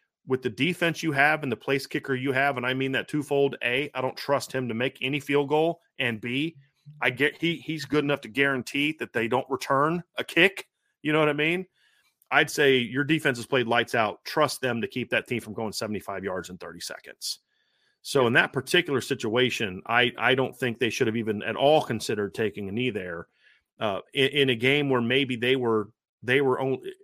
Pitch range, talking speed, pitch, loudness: 125-145 Hz, 220 wpm, 135 Hz, -25 LUFS